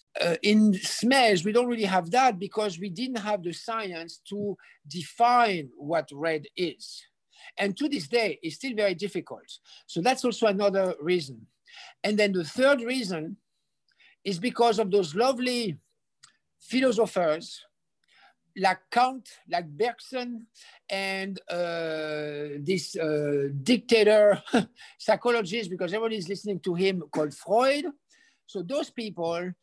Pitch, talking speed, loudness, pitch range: 200 Hz, 130 wpm, -26 LUFS, 175-235 Hz